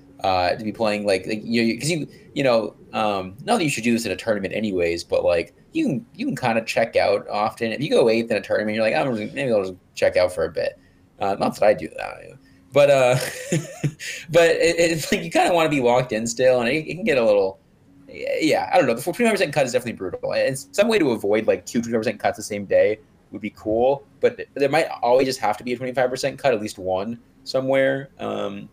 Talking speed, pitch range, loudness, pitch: 260 wpm, 110-170 Hz, -21 LUFS, 130 Hz